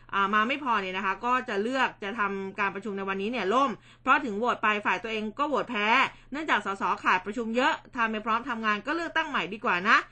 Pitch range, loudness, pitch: 200-245 Hz, -27 LUFS, 220 Hz